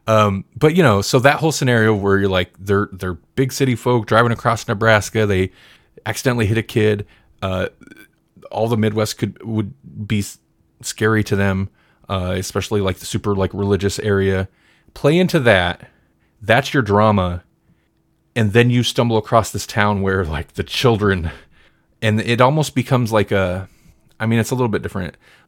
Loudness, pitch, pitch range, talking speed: -18 LUFS, 105 Hz, 95-120 Hz, 170 wpm